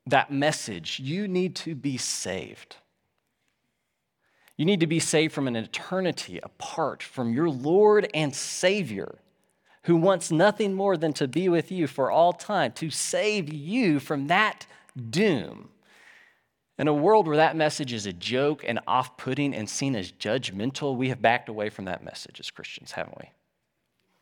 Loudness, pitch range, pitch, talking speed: -26 LUFS, 130-180 Hz, 150 Hz, 165 wpm